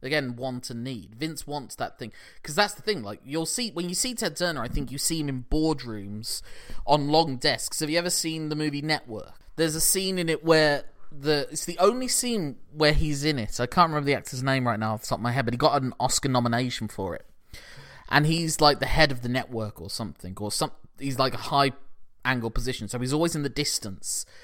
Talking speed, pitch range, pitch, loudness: 240 wpm, 125-160 Hz, 145 Hz, -26 LUFS